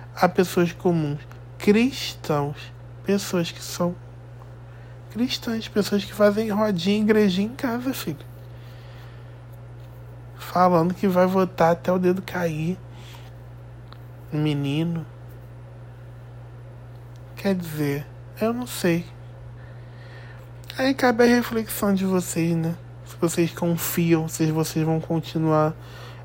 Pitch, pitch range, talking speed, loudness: 150 Hz, 120-180 Hz, 100 wpm, -23 LUFS